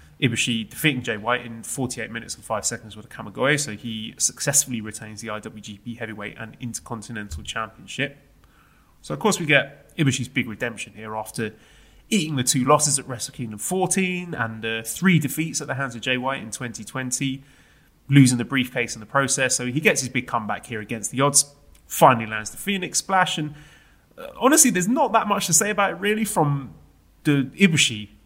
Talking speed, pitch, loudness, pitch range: 190 wpm, 125 Hz, -22 LUFS, 115-150 Hz